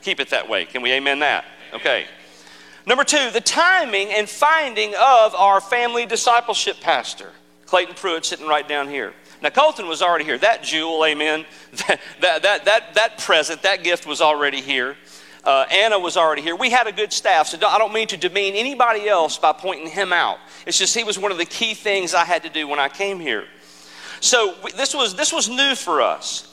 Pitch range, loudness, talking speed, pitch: 155-230 Hz, -18 LUFS, 210 wpm, 195 Hz